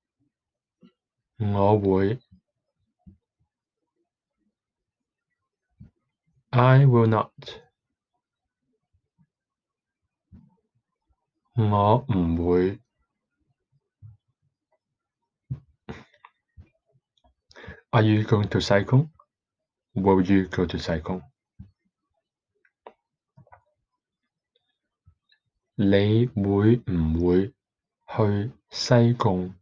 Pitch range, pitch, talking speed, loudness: 95-125 Hz, 105 Hz, 40 wpm, -23 LUFS